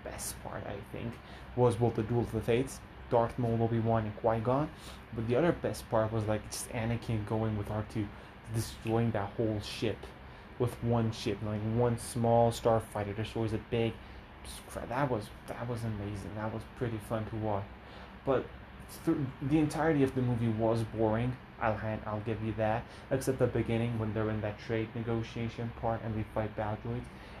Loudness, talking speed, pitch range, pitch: -33 LUFS, 180 wpm, 110-120 Hz, 115 Hz